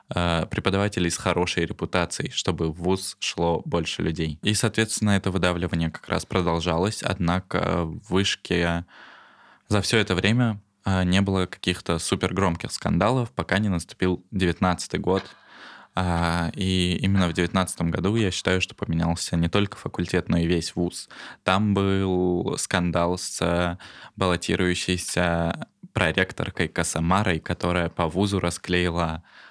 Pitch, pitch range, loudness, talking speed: 90 Hz, 85-95 Hz, -24 LUFS, 125 wpm